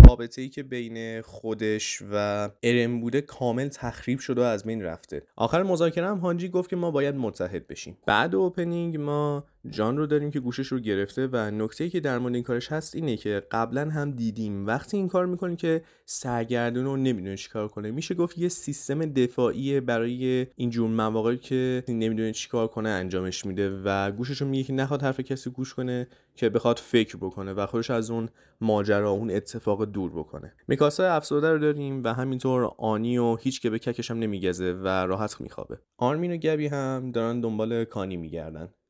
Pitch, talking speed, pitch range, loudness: 120 Hz, 190 wpm, 110-140 Hz, -27 LUFS